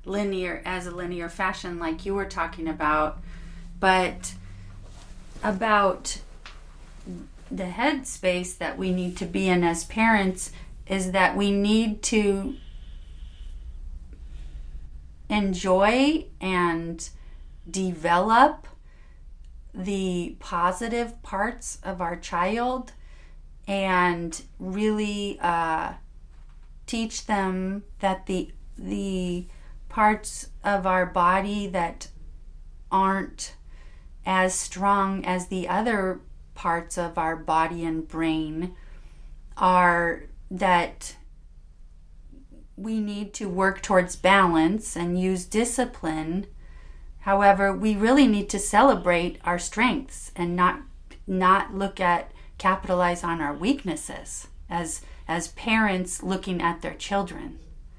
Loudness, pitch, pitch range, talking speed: -25 LUFS, 180 Hz, 155-195 Hz, 100 wpm